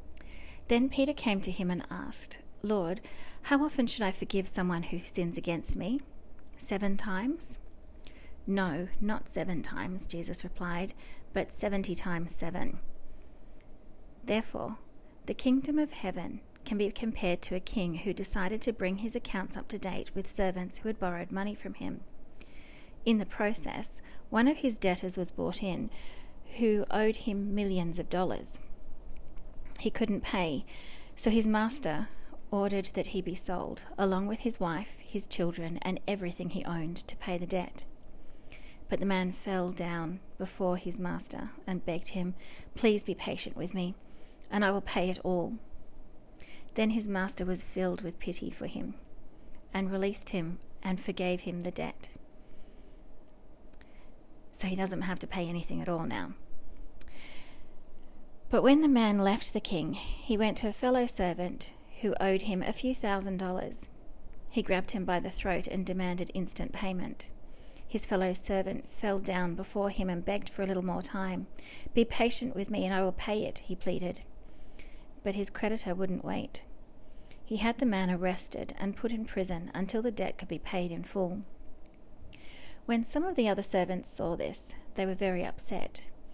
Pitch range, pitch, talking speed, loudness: 180-215 Hz, 190 Hz, 165 wpm, -32 LUFS